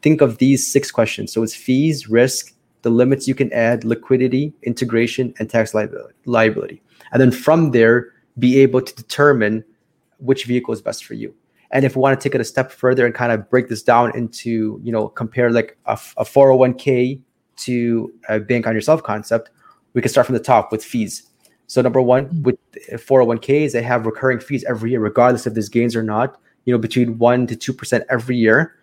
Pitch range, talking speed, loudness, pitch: 115-130 Hz, 200 wpm, -17 LUFS, 125 Hz